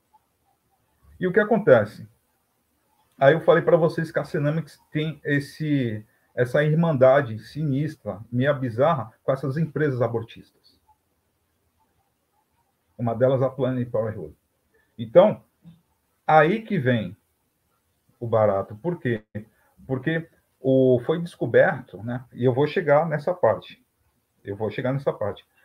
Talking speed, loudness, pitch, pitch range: 125 wpm, -23 LUFS, 130 Hz, 110-155 Hz